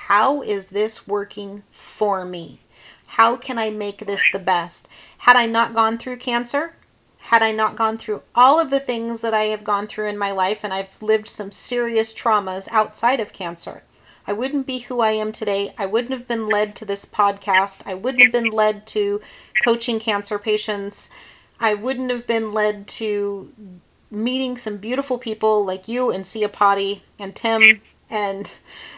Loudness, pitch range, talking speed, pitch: -20 LUFS, 205-230 Hz, 180 wpm, 215 Hz